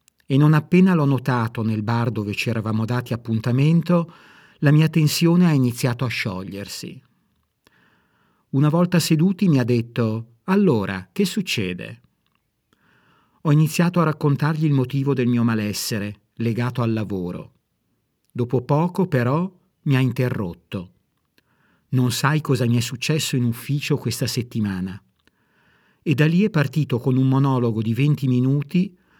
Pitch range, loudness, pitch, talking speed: 115-155 Hz, -21 LUFS, 130 Hz, 140 wpm